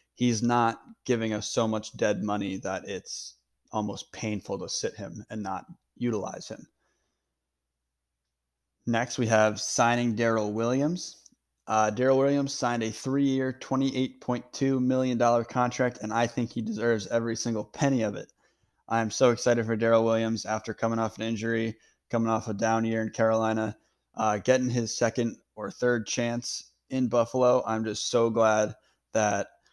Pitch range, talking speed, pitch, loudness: 110-120 Hz, 155 wpm, 115 Hz, -28 LUFS